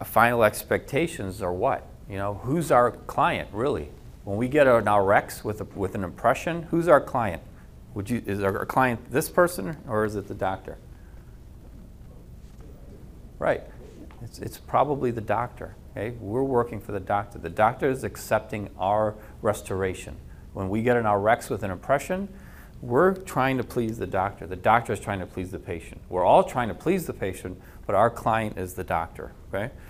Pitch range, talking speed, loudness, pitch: 95-120 Hz, 180 wpm, -25 LUFS, 105 Hz